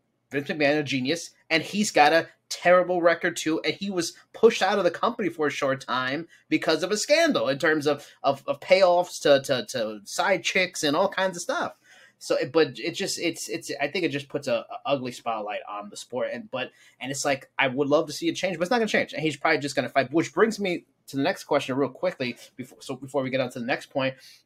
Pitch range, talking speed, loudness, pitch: 140-180 Hz, 255 wpm, -25 LUFS, 160 Hz